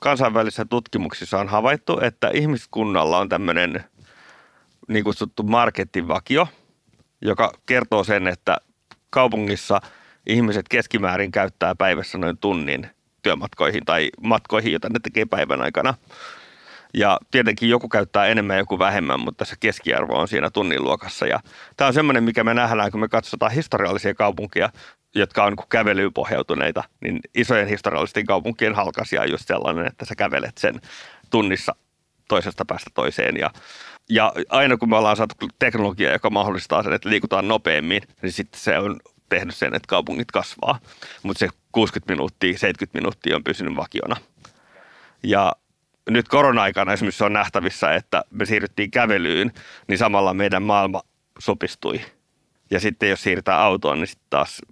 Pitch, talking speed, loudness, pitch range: 105 Hz, 145 wpm, -21 LUFS, 100-115 Hz